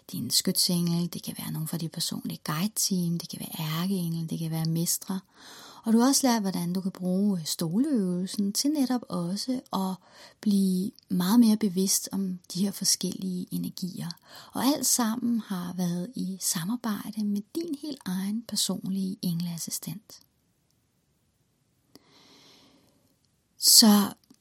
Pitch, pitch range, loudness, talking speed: 195 Hz, 180-220 Hz, -27 LUFS, 140 wpm